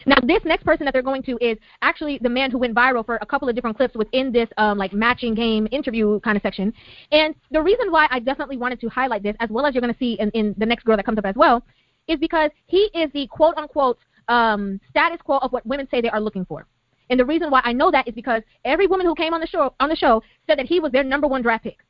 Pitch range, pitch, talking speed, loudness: 225-295 Hz, 255 Hz, 285 wpm, -20 LUFS